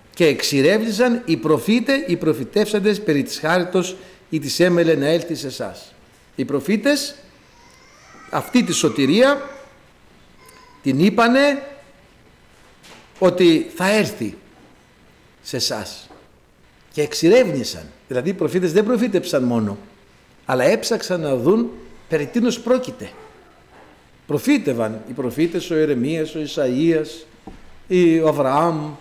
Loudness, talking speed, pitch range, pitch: -19 LUFS, 110 wpm, 150-220 Hz, 170 Hz